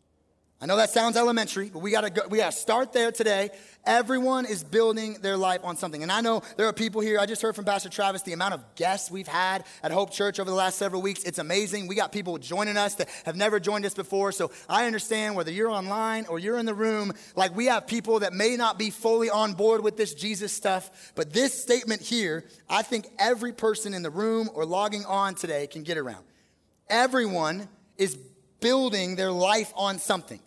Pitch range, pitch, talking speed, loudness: 190-220 Hz, 205 Hz, 220 wpm, -26 LUFS